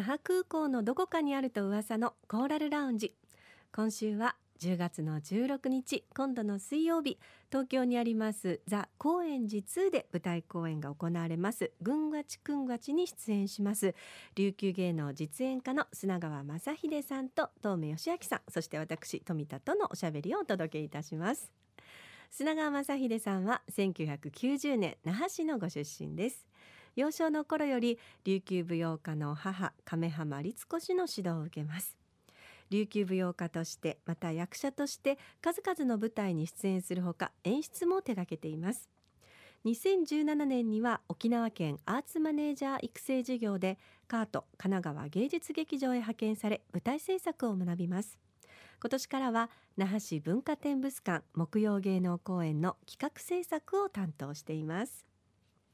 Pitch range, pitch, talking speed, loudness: 175-275 Hz, 215 Hz, 290 characters per minute, -35 LUFS